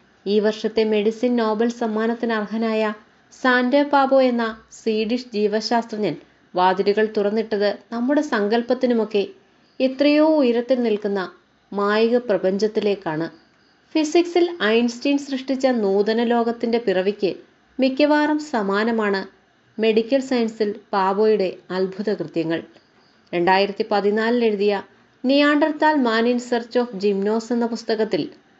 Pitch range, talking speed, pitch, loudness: 205-245 Hz, 90 wpm, 225 Hz, -20 LUFS